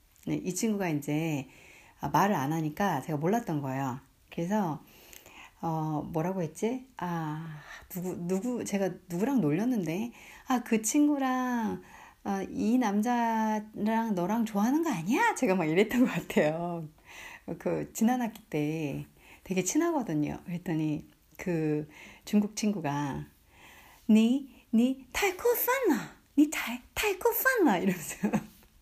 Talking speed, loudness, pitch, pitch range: 235 characters per minute, -30 LUFS, 200 Hz, 160-245 Hz